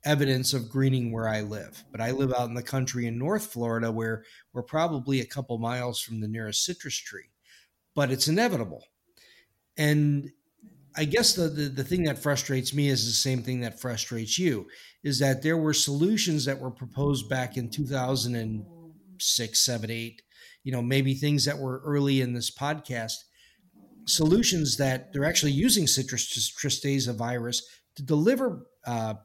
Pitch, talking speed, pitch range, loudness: 135 Hz, 165 wpm, 120-150 Hz, -27 LUFS